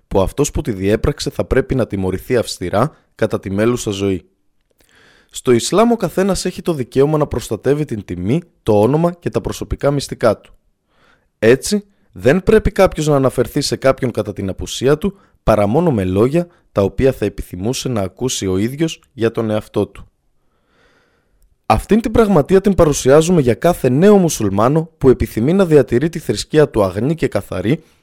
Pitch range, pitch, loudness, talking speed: 105-165 Hz, 130 Hz, -16 LUFS, 170 wpm